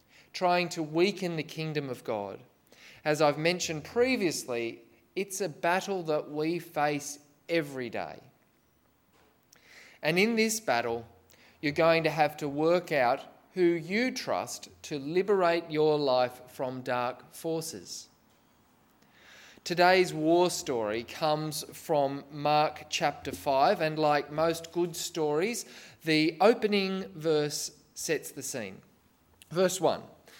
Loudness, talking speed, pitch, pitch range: -29 LUFS, 120 wpm, 155 Hz, 145-175 Hz